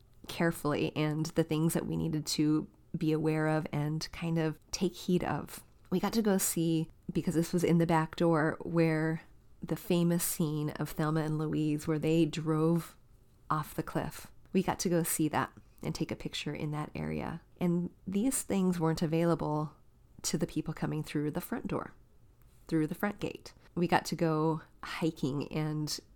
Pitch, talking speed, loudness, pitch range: 160 Hz, 180 wpm, -32 LUFS, 150-170 Hz